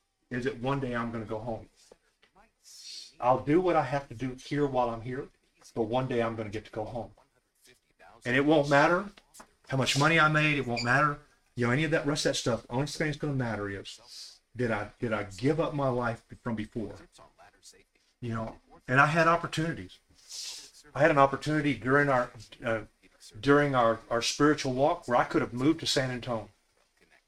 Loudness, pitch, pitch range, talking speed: -28 LUFS, 130 Hz, 115-145 Hz, 205 wpm